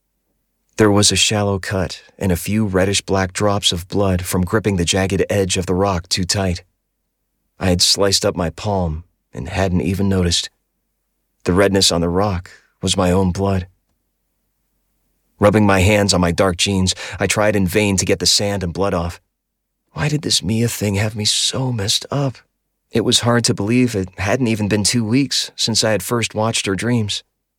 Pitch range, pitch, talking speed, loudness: 90-105 Hz, 100 Hz, 190 wpm, -17 LUFS